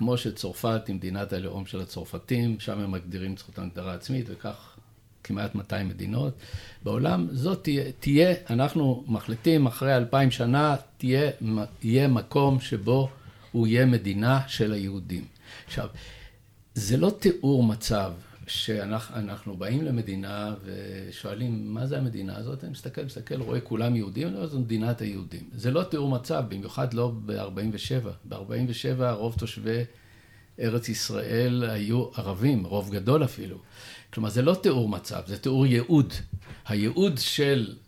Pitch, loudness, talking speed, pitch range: 115 Hz, -27 LUFS, 145 wpm, 100-130 Hz